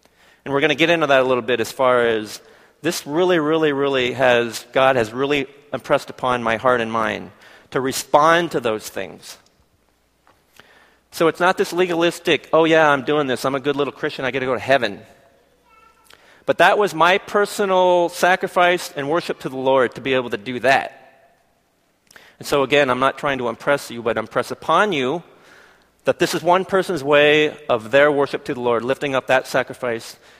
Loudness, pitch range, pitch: -18 LUFS, 125-170 Hz, 145 Hz